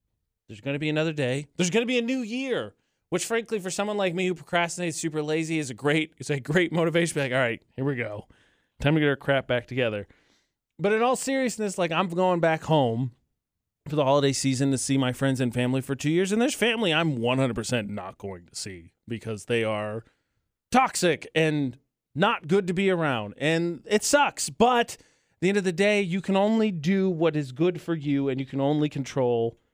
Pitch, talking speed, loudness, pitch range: 155 Hz, 220 wpm, -25 LUFS, 130-185 Hz